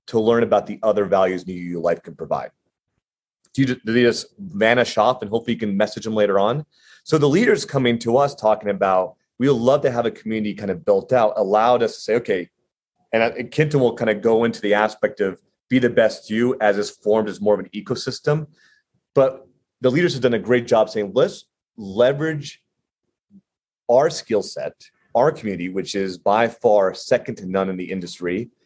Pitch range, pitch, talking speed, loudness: 105-130 Hz, 115 Hz, 205 wpm, -20 LUFS